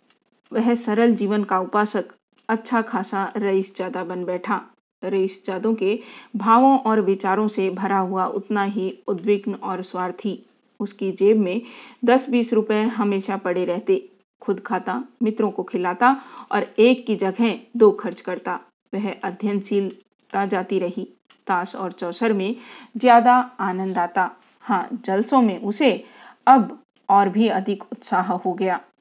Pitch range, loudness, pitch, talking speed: 190-230 Hz, -21 LUFS, 205 Hz, 140 wpm